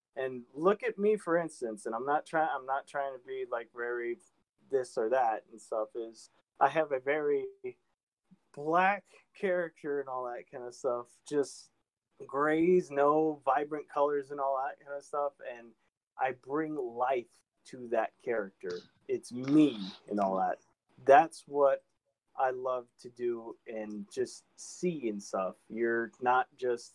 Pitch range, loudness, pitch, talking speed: 120-175 Hz, -32 LUFS, 140 Hz, 160 wpm